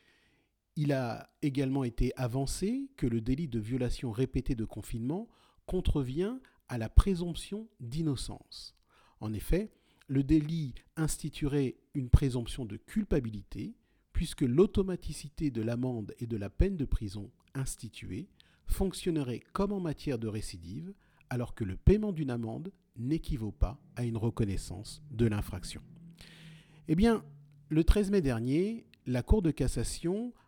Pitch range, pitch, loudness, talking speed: 115-165 Hz, 140 Hz, -33 LUFS, 135 wpm